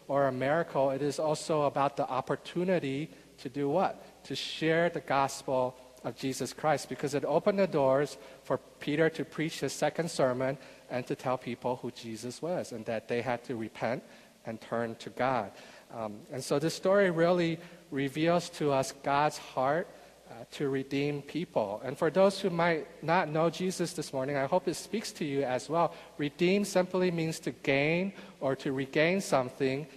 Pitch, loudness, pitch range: 145 Hz, -31 LUFS, 135-165 Hz